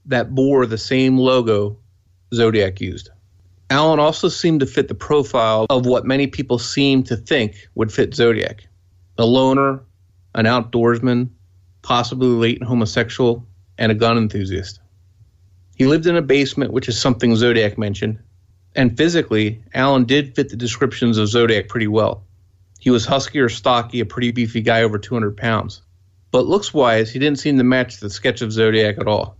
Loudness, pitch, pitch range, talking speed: -17 LUFS, 115 Hz, 105-130 Hz, 170 wpm